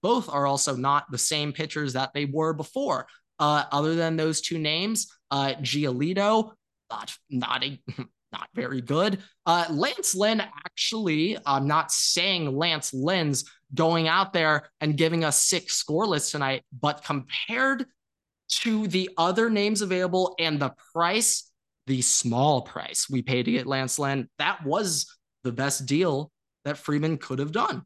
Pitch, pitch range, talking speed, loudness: 155 Hz, 140-185 Hz, 155 wpm, -25 LUFS